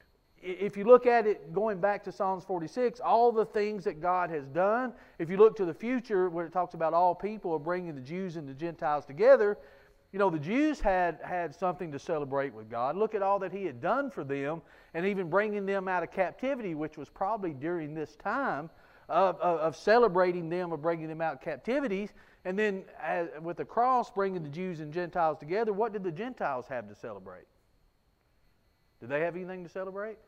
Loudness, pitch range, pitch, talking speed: -30 LUFS, 170-210 Hz, 185 Hz, 210 wpm